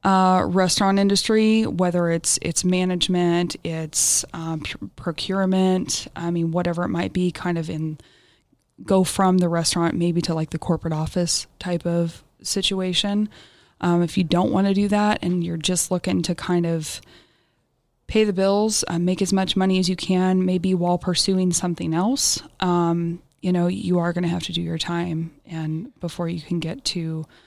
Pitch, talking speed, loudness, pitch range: 175 Hz, 180 wpm, -22 LUFS, 170-185 Hz